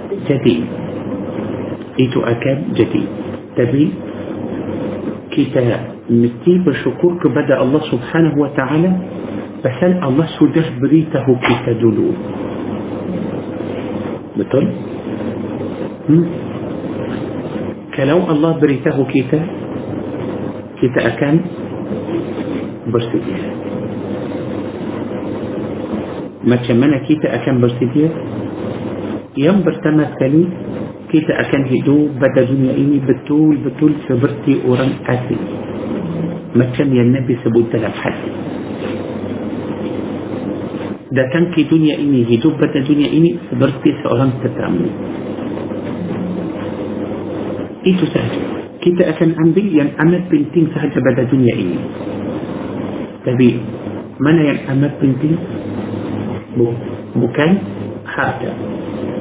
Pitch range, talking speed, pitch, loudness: 125-160 Hz, 80 wpm, 145 Hz, -17 LUFS